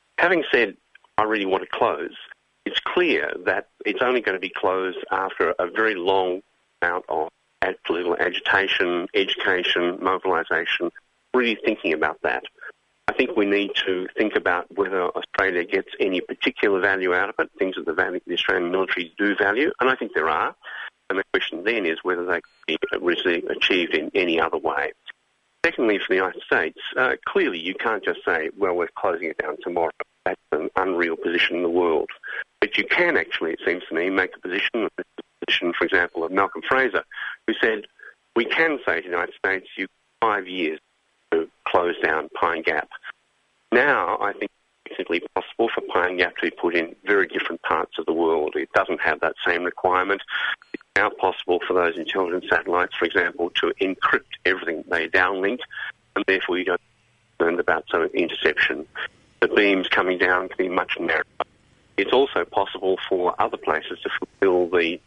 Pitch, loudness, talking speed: 390 Hz, -23 LUFS, 180 wpm